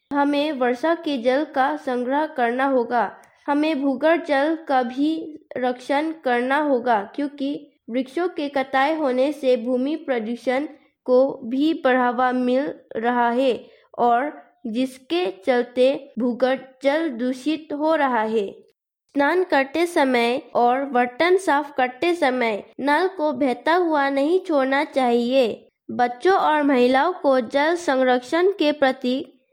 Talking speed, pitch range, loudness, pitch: 125 wpm, 255-300 Hz, -21 LUFS, 275 Hz